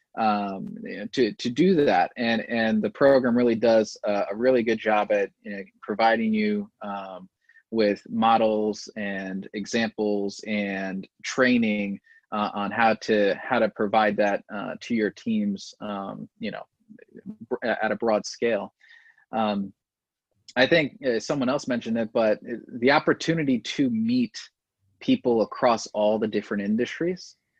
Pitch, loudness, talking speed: 115 Hz, -25 LUFS, 150 wpm